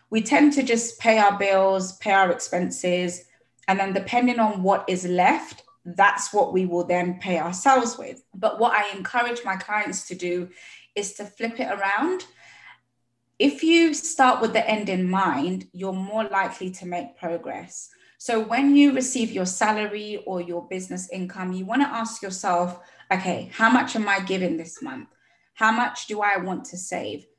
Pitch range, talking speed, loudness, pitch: 180-230 Hz, 175 wpm, -23 LUFS, 195 Hz